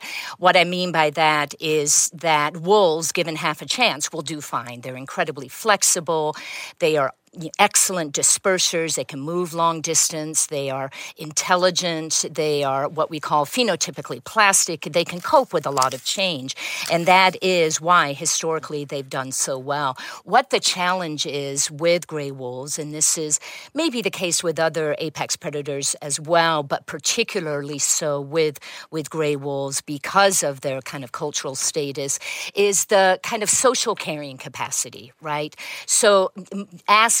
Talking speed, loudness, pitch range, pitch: 155 wpm, -20 LUFS, 145-180 Hz, 160 Hz